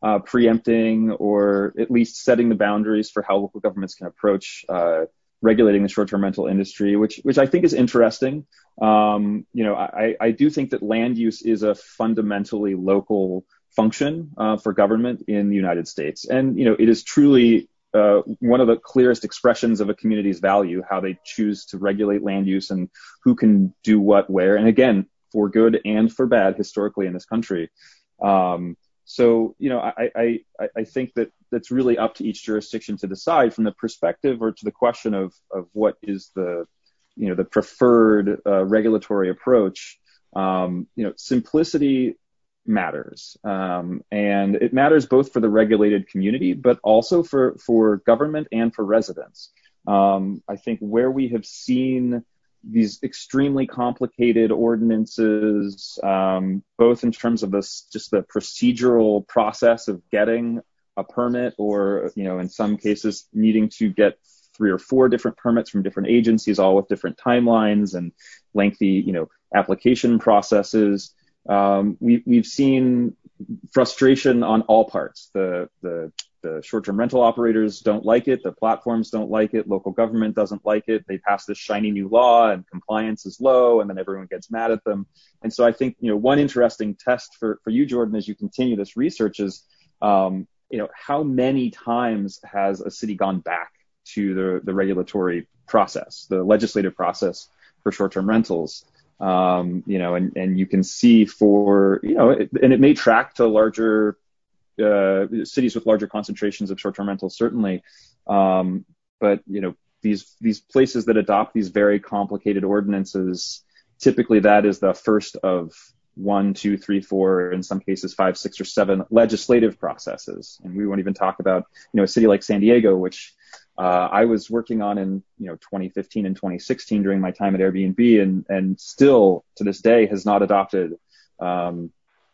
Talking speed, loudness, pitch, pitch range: 175 wpm, -20 LUFS, 105 Hz, 100-115 Hz